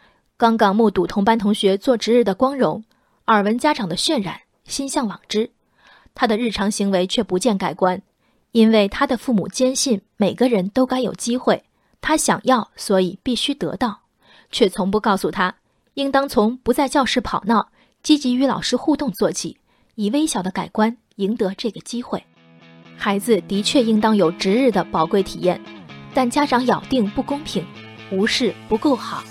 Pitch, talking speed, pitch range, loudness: 220 Hz, 255 characters per minute, 195-255 Hz, -19 LUFS